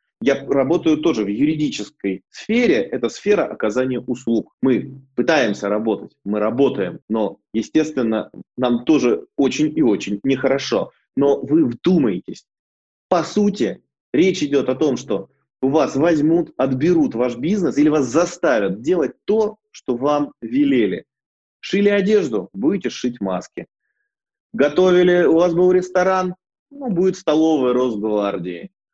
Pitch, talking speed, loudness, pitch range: 155 Hz, 125 wpm, -19 LUFS, 125-190 Hz